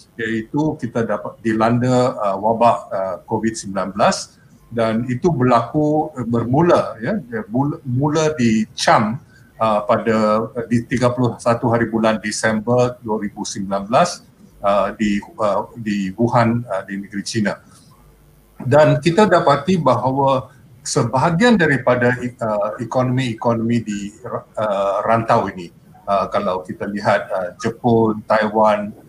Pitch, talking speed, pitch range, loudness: 120 Hz, 85 wpm, 110-130 Hz, -18 LUFS